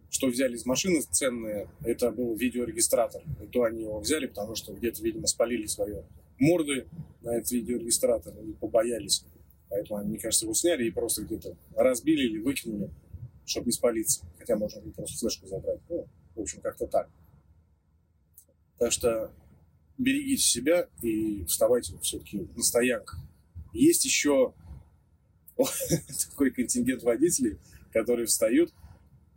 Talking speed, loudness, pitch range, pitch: 135 wpm, -28 LUFS, 105-165 Hz, 120 Hz